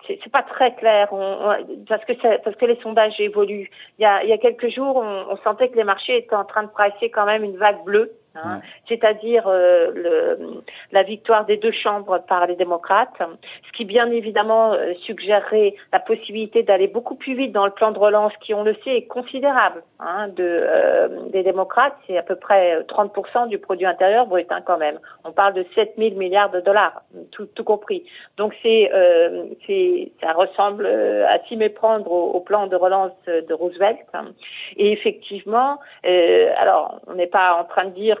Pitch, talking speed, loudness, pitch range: 210 Hz, 200 wpm, -19 LUFS, 195-235 Hz